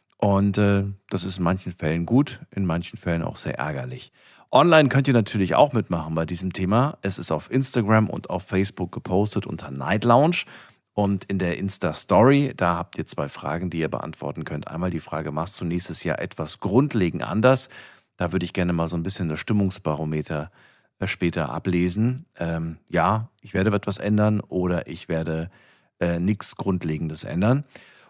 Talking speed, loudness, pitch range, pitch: 175 wpm, -24 LUFS, 85-105 Hz, 95 Hz